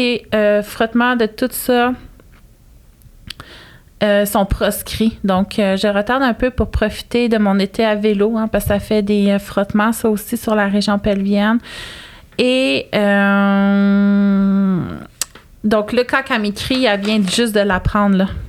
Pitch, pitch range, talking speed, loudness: 210 Hz, 200-230 Hz, 155 wpm, -16 LUFS